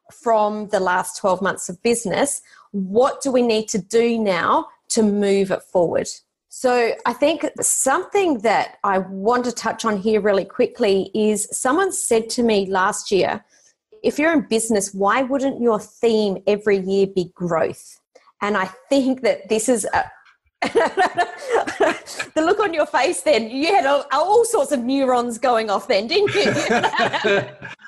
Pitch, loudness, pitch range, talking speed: 230 Hz, -19 LUFS, 205-285 Hz, 160 wpm